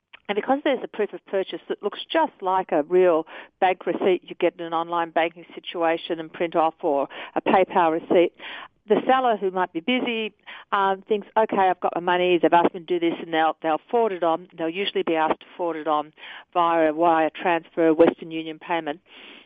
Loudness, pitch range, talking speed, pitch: -23 LUFS, 165-195 Hz, 215 wpm, 175 Hz